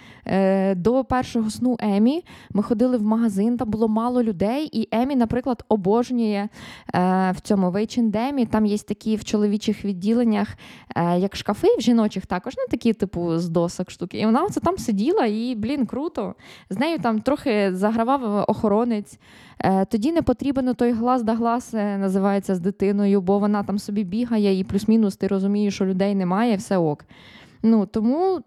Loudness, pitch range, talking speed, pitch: -22 LUFS, 200-240 Hz, 165 wpm, 215 Hz